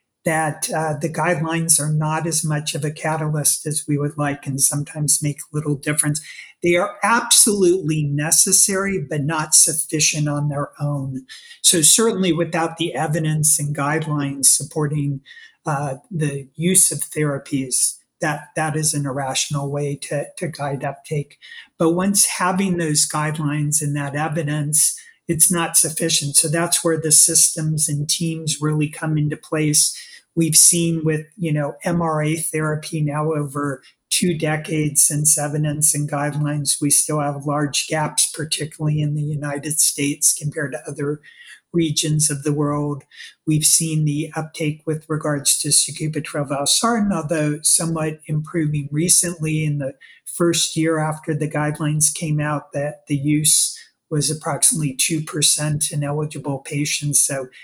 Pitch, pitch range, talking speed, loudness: 155 Hz, 145-160 Hz, 145 wpm, -18 LUFS